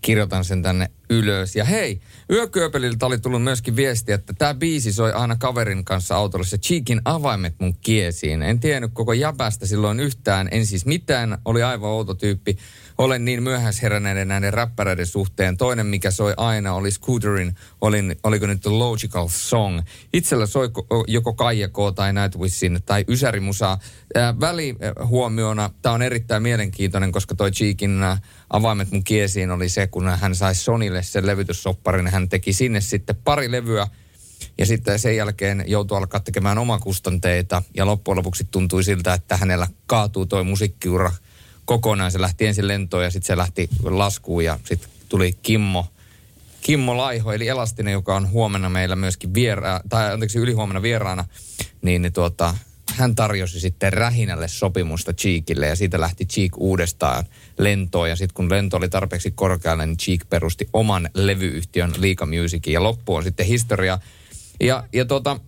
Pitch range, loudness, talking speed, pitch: 95-115 Hz, -21 LUFS, 155 wpm, 100 Hz